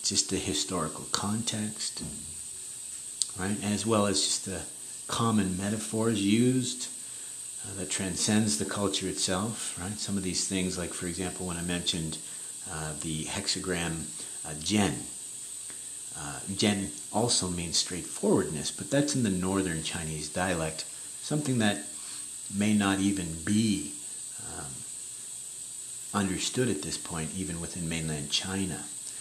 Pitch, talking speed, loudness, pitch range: 95 Hz, 125 wpm, -30 LUFS, 85-105 Hz